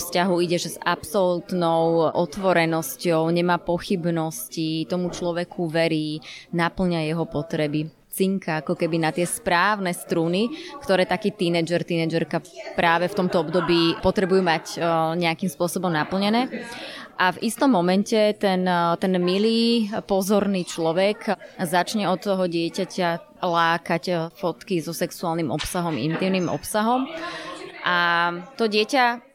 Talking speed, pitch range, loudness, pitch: 115 wpm, 165-195 Hz, -23 LUFS, 175 Hz